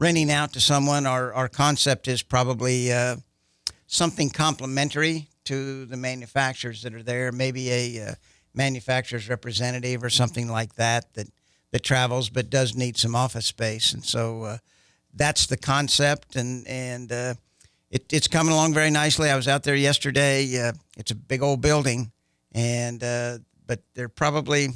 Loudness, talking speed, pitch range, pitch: -24 LUFS, 160 wpm, 120-140 Hz, 130 Hz